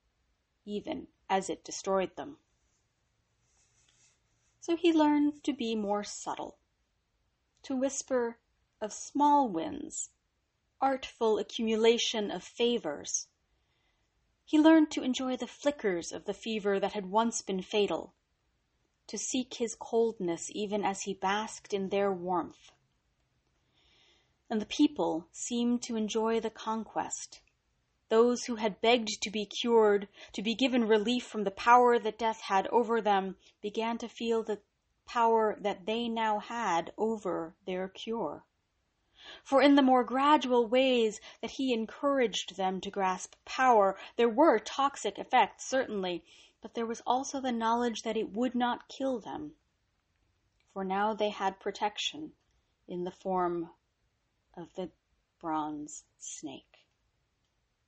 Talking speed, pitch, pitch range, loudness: 130 wpm, 220 Hz, 195-245 Hz, -30 LUFS